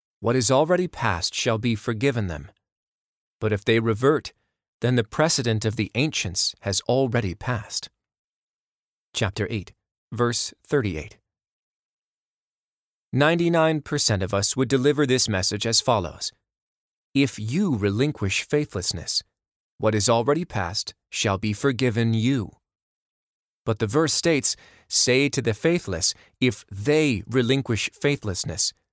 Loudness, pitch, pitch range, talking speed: -23 LUFS, 115 Hz, 105-135 Hz, 125 wpm